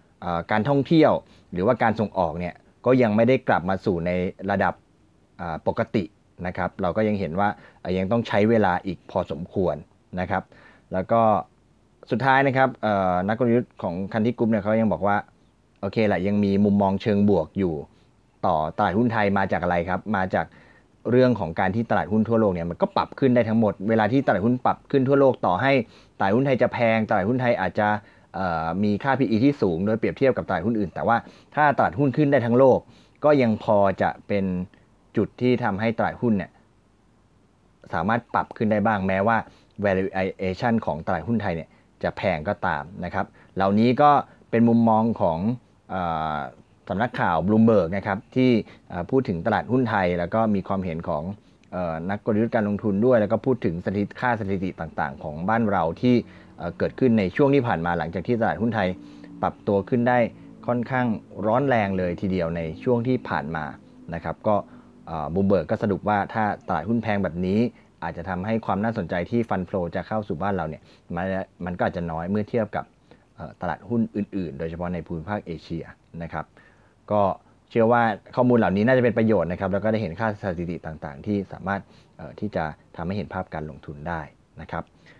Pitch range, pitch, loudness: 95-115 Hz, 105 Hz, -23 LUFS